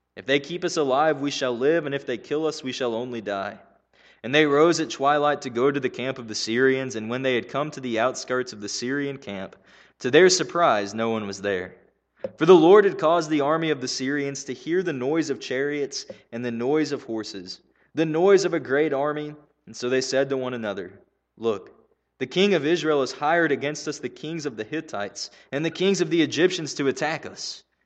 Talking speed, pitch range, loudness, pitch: 230 wpm, 125-155 Hz, -23 LUFS, 140 Hz